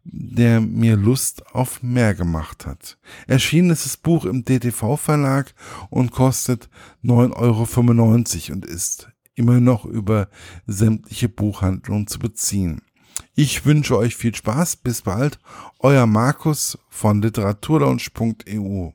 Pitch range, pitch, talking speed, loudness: 105-130 Hz, 120 Hz, 115 wpm, -19 LUFS